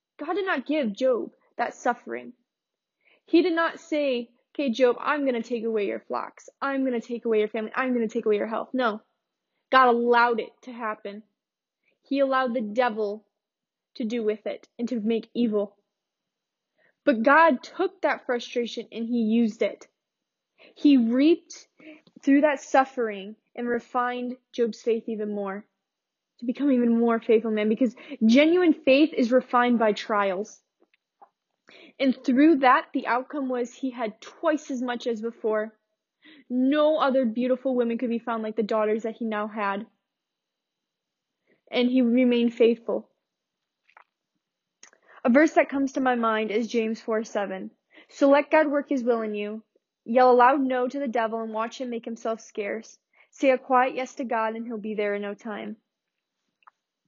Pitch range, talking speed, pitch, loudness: 220-270 Hz, 170 wpm, 240 Hz, -25 LUFS